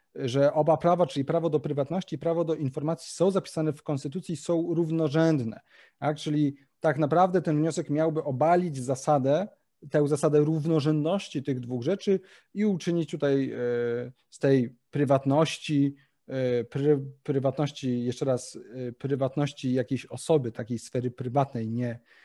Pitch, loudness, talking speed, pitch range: 150 Hz, -27 LUFS, 140 wpm, 135-160 Hz